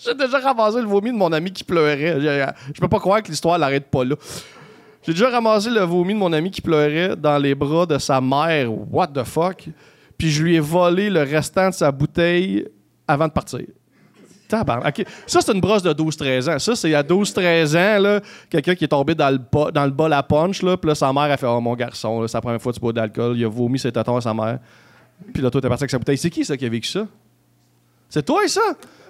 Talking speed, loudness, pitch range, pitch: 245 wpm, -19 LUFS, 135-185 Hz, 155 Hz